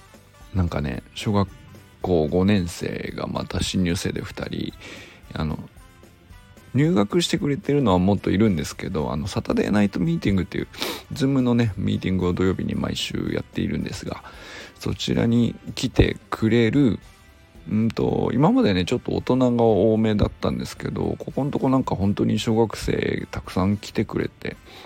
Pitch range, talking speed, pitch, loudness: 90-115 Hz, 340 characters per minute, 105 Hz, -23 LUFS